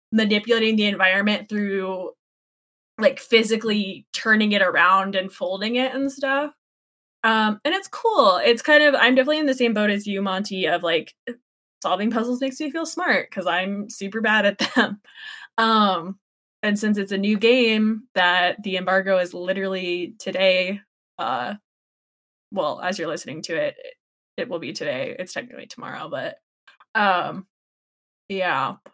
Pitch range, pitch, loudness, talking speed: 190-255 Hz, 215 Hz, -21 LUFS, 155 wpm